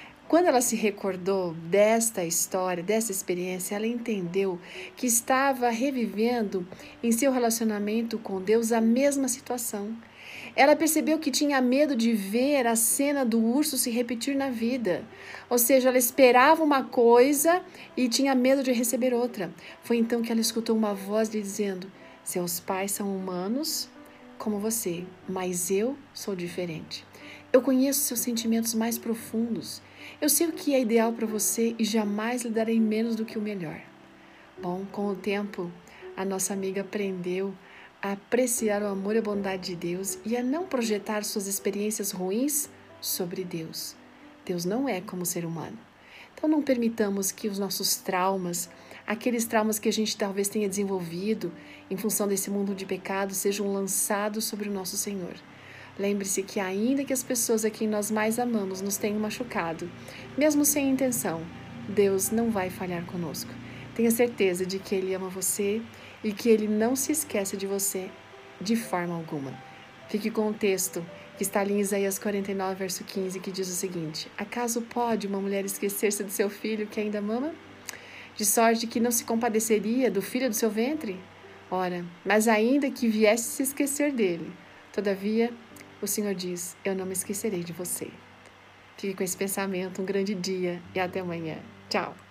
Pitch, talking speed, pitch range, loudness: 210 Hz, 170 wpm, 190-235 Hz, -27 LUFS